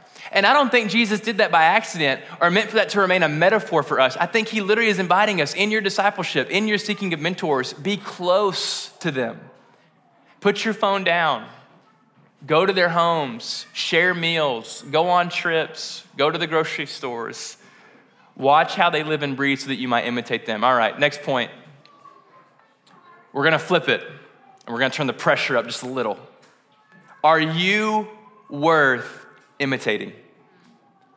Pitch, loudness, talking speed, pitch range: 180 Hz, -20 LUFS, 175 wpm, 160-210 Hz